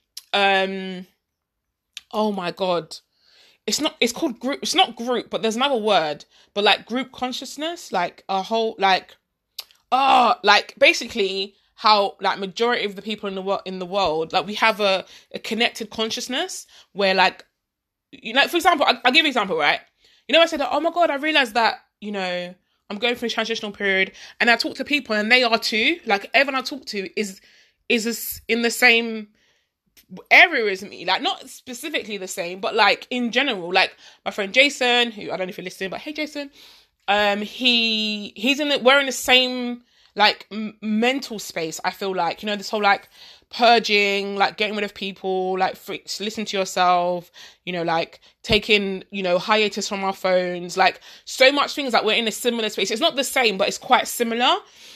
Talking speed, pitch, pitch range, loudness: 200 wpm, 215 Hz, 195-250 Hz, -20 LUFS